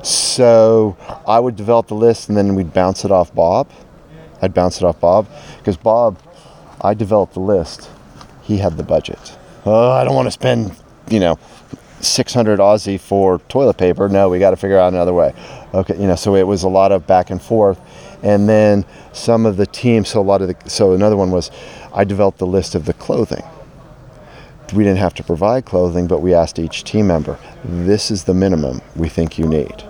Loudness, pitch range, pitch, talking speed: -15 LUFS, 90-105 Hz, 95 Hz, 205 wpm